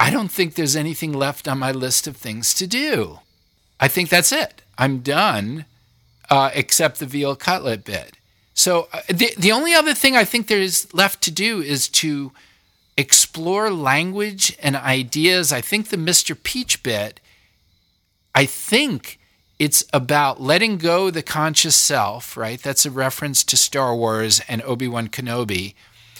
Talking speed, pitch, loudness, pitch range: 160 wpm, 140 Hz, -18 LUFS, 120-180 Hz